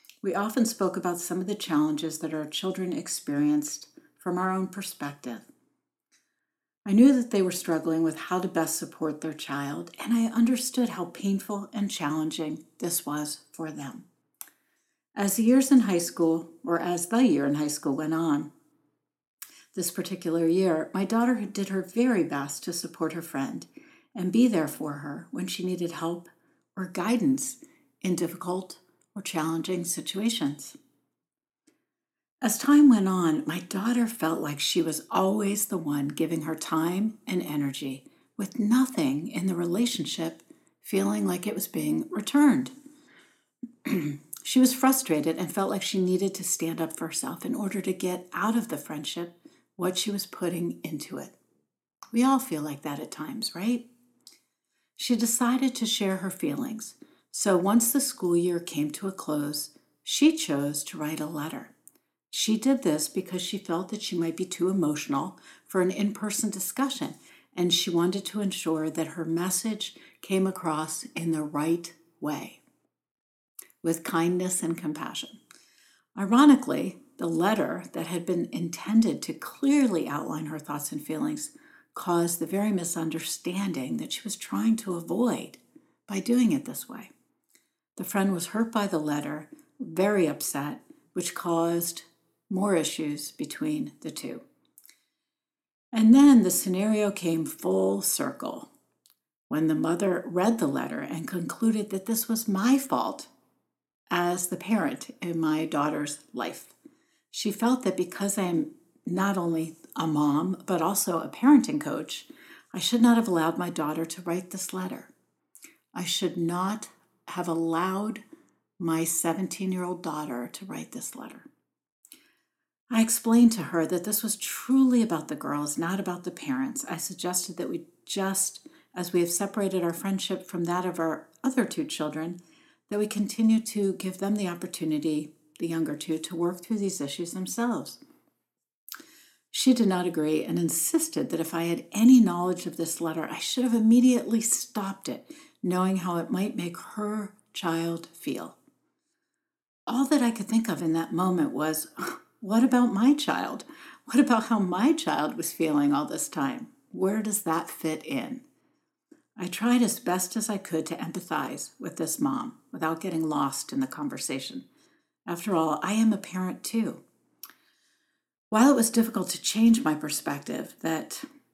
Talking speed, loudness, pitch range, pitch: 160 wpm, -27 LUFS, 165-240 Hz, 190 Hz